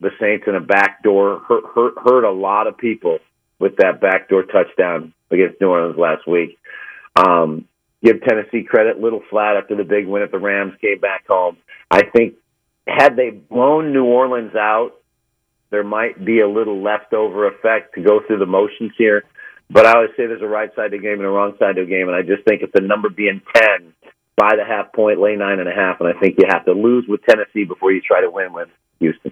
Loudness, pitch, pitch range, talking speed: -16 LUFS, 105 Hz, 100-140 Hz, 220 wpm